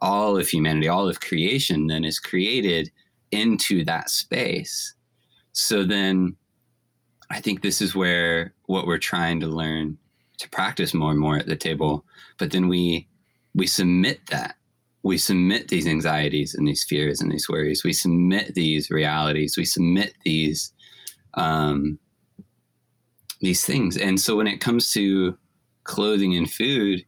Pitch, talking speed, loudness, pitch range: 85 Hz, 150 wpm, -22 LUFS, 75-95 Hz